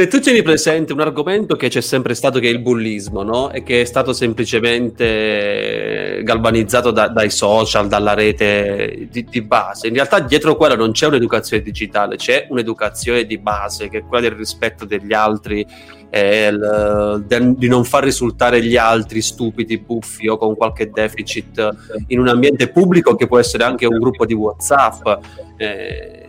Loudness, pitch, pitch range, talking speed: -15 LUFS, 115 Hz, 105-125 Hz, 170 wpm